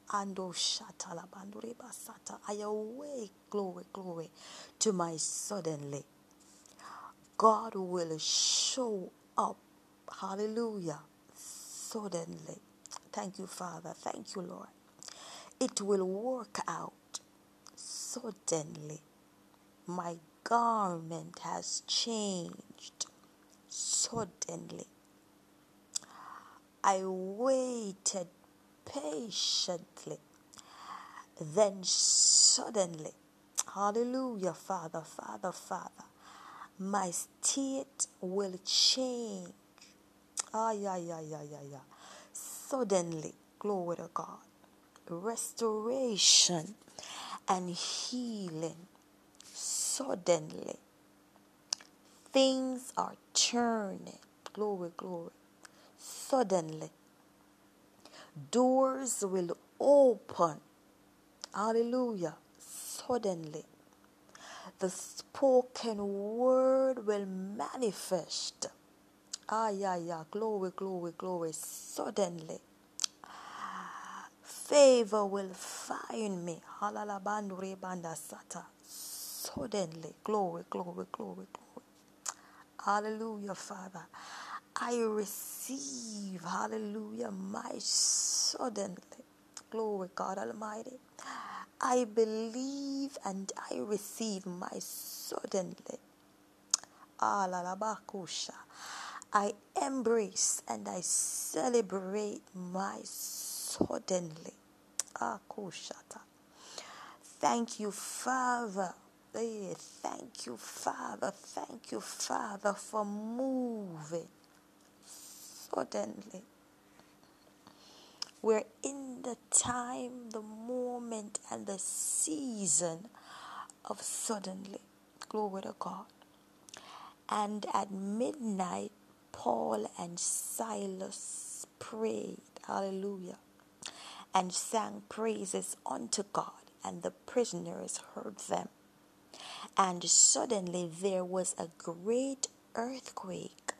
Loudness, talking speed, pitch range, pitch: -34 LUFS, 70 wpm, 180-235 Hz, 205 Hz